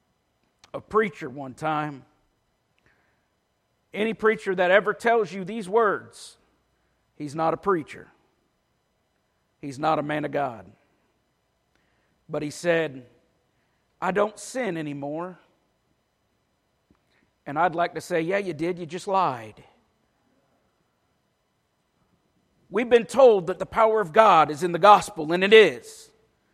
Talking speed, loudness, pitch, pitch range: 125 wpm, -23 LUFS, 180 Hz, 155-210 Hz